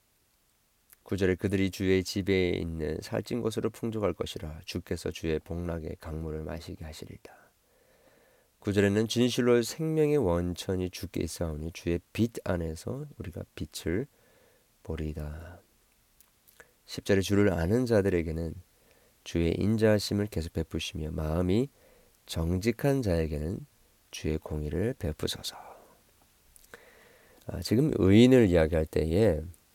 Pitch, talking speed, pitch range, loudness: 90 Hz, 260 characters per minute, 80-110 Hz, -29 LUFS